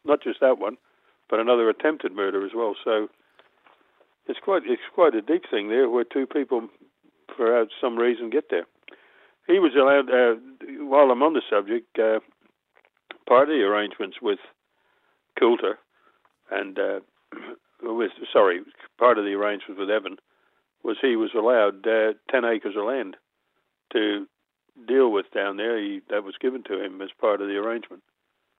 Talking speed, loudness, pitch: 165 wpm, -23 LUFS, 295 Hz